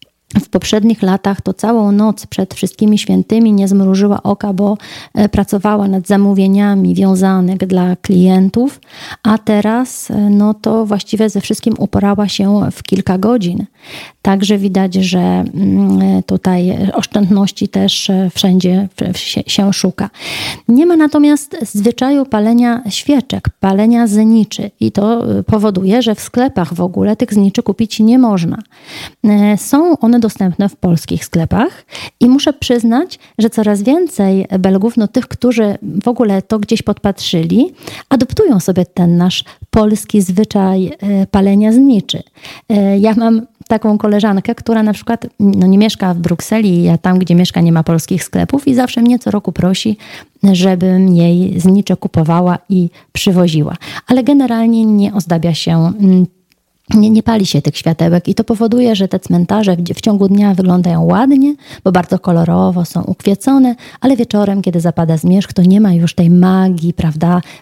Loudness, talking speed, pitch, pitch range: -12 LUFS, 145 wpm, 200 Hz, 185-225 Hz